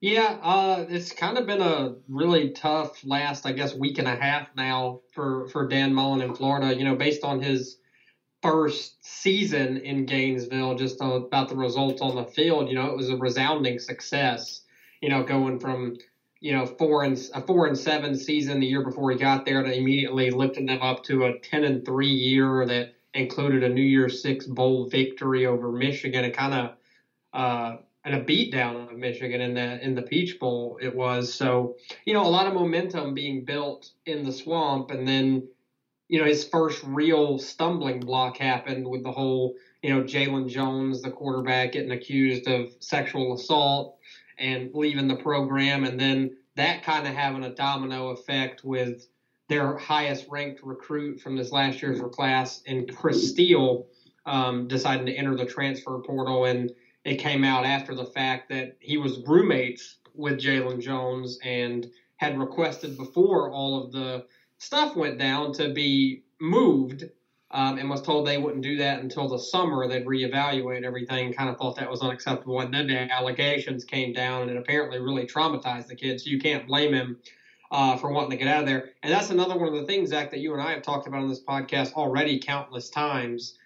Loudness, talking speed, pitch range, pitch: -26 LUFS, 190 wpm, 130-145 Hz, 135 Hz